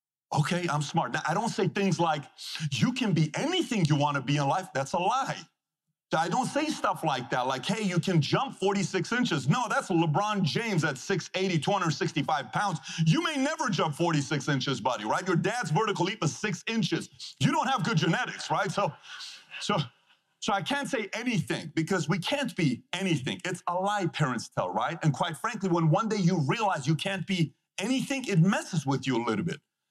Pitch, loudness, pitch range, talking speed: 175 Hz, -28 LUFS, 155-200 Hz, 205 wpm